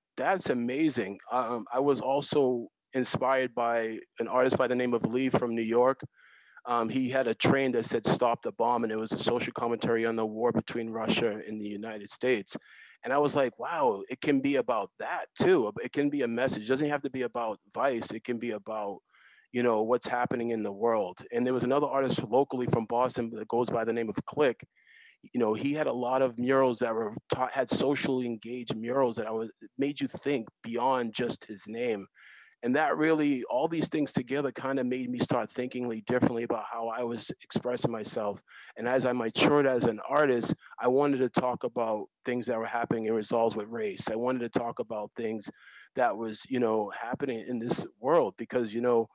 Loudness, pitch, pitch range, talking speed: -30 LUFS, 125 Hz, 115-130 Hz, 210 wpm